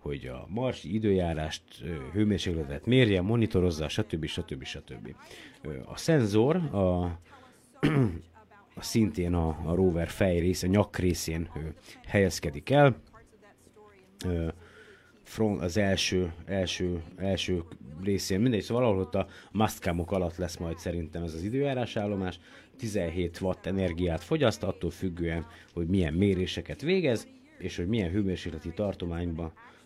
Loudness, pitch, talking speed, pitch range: -29 LUFS, 90 Hz, 120 wpm, 85-105 Hz